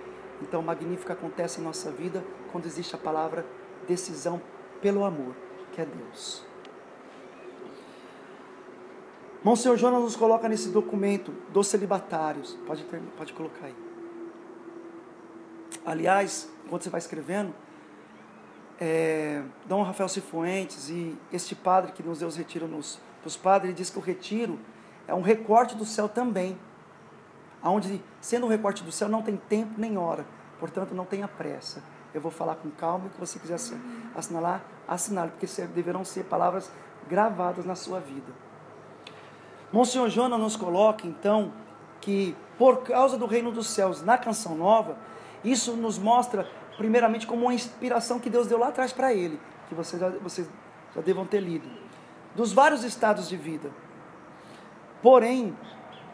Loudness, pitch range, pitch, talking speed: -27 LUFS, 175-230 Hz, 195 Hz, 150 wpm